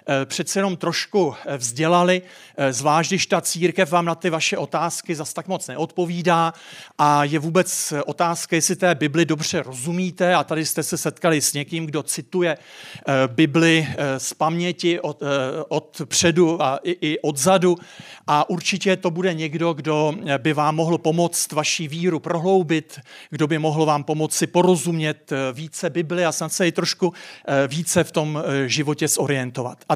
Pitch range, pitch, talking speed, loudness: 150-175 Hz, 165 Hz, 155 wpm, -21 LUFS